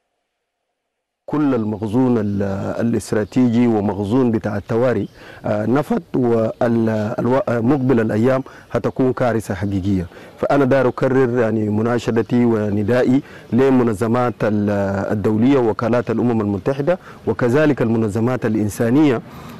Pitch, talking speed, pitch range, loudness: 120 Hz, 80 wpm, 110-130 Hz, -18 LUFS